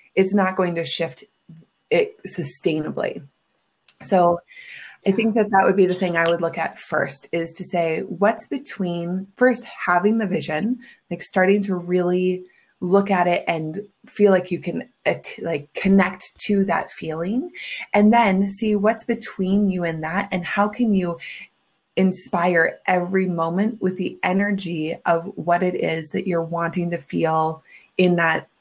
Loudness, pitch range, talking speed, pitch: -21 LUFS, 170-200 Hz, 160 wpm, 185 Hz